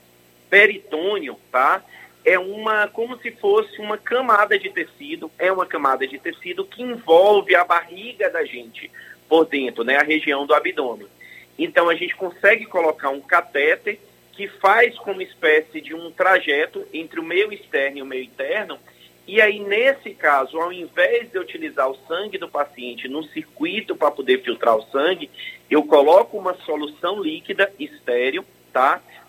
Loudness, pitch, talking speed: -19 LUFS, 200 Hz, 160 wpm